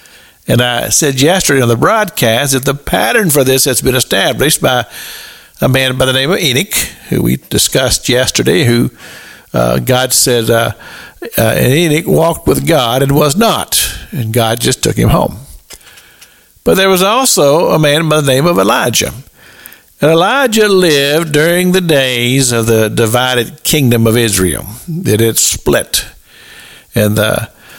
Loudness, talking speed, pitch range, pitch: -10 LUFS, 160 wpm, 120-165 Hz, 135 Hz